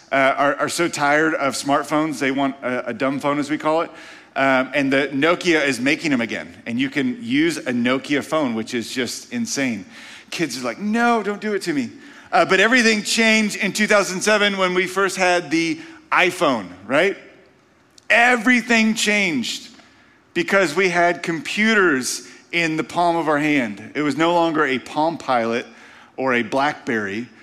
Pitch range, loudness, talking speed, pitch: 145-230 Hz, -19 LUFS, 175 wpm, 175 Hz